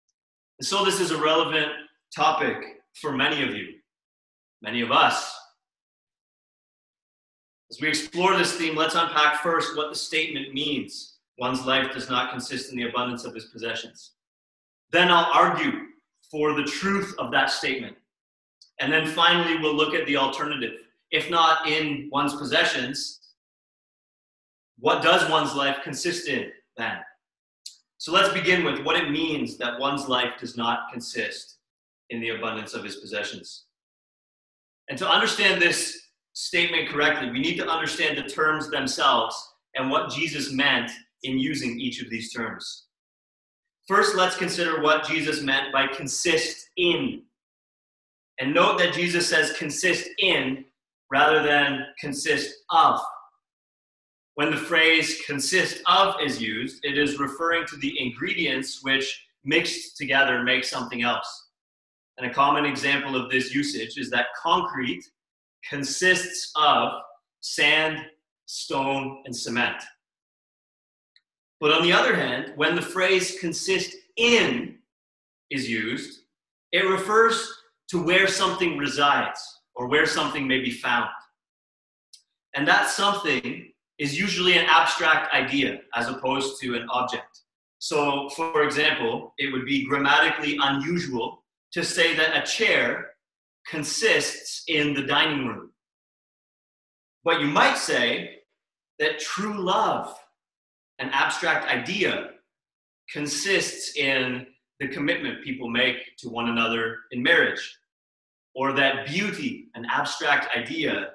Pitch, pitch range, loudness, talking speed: 150 Hz, 135-175 Hz, -23 LUFS, 130 wpm